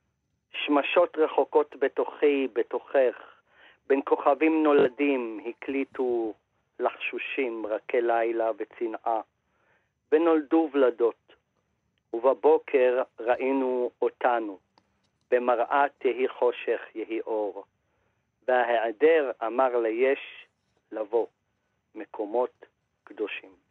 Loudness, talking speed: -26 LUFS, 75 wpm